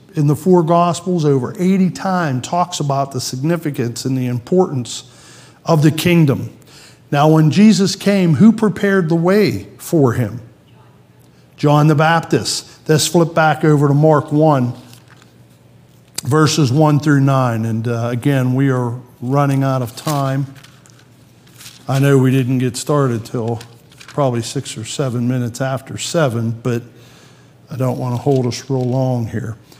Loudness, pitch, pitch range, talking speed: -15 LUFS, 140 Hz, 125-155 Hz, 150 wpm